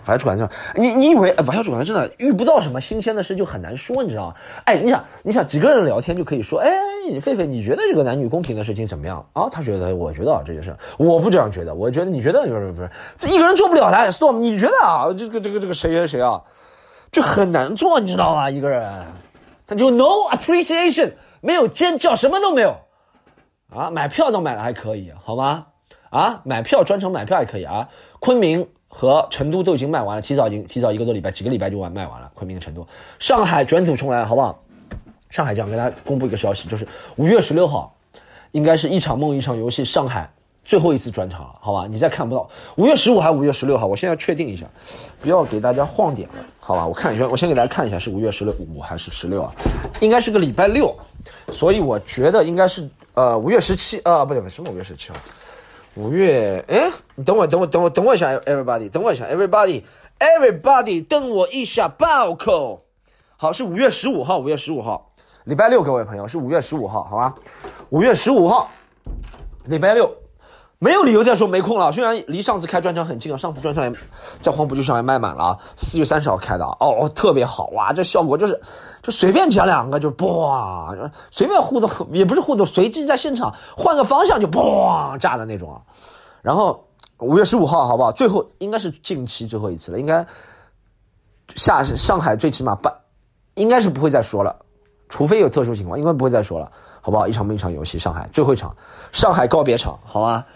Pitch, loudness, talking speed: 150 Hz, -18 LUFS, 360 characters per minute